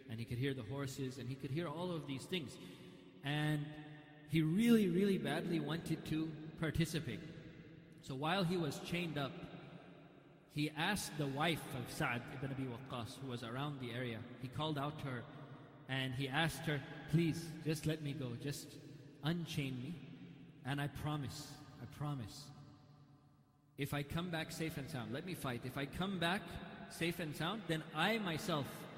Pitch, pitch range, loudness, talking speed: 150 Hz, 140-160 Hz, -41 LUFS, 175 wpm